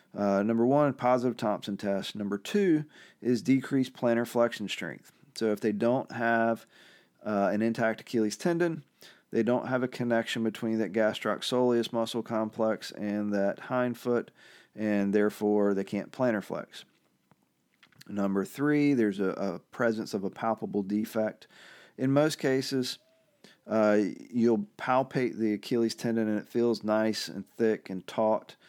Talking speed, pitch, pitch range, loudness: 145 wpm, 115 Hz, 105-125 Hz, -29 LUFS